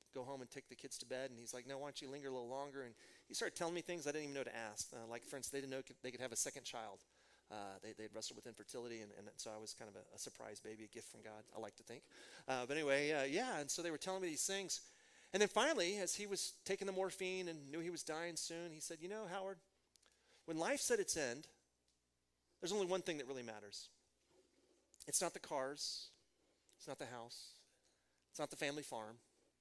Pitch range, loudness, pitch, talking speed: 115-175 Hz, -45 LUFS, 140 Hz, 255 wpm